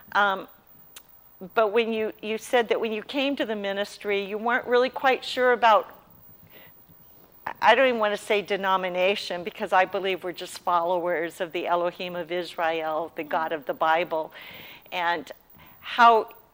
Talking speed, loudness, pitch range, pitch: 160 wpm, -25 LUFS, 175-225 Hz, 200 Hz